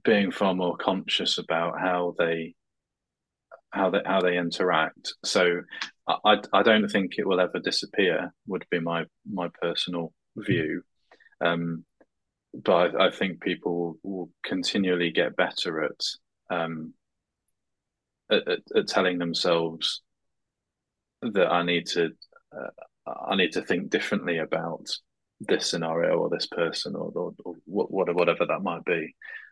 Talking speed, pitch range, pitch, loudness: 135 wpm, 85-100 Hz, 85 Hz, -26 LUFS